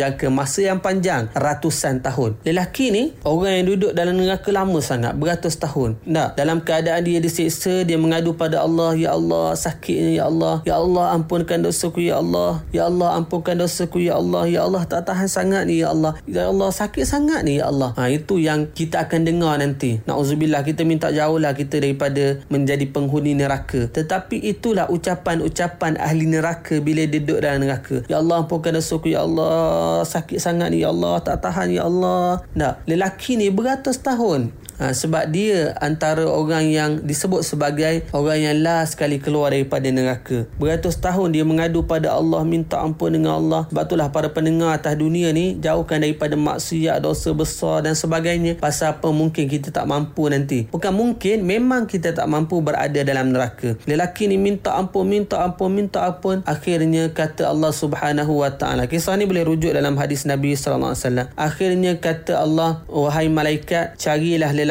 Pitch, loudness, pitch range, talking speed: 160 Hz, -20 LUFS, 145-175 Hz, 180 wpm